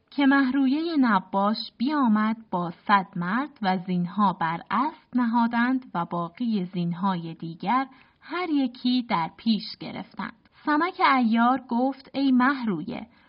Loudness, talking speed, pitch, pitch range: -25 LUFS, 115 wpm, 235 Hz, 190-260 Hz